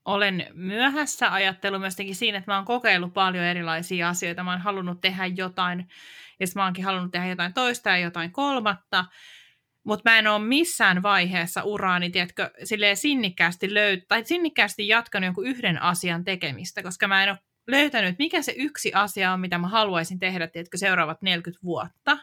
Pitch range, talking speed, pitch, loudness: 180-210 Hz, 160 wpm, 190 Hz, -23 LUFS